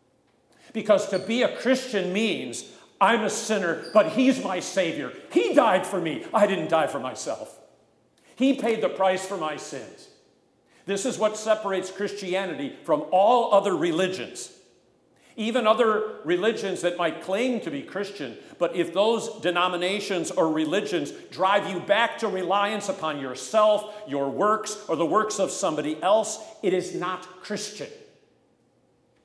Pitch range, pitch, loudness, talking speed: 180-220 Hz, 200 Hz, -25 LUFS, 150 wpm